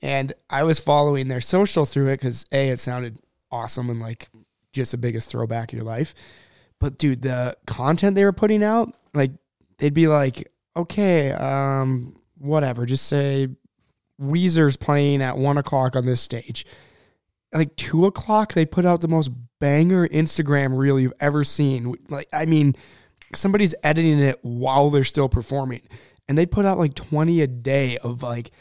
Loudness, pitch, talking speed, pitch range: -21 LUFS, 140 Hz, 170 wpm, 125-155 Hz